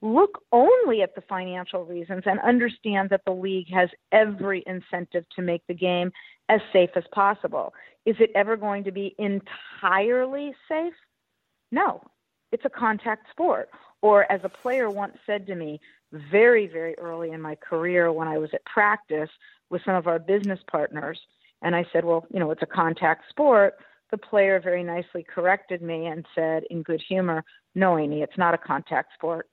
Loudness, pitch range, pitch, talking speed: -24 LUFS, 170-210 Hz, 190 Hz, 180 wpm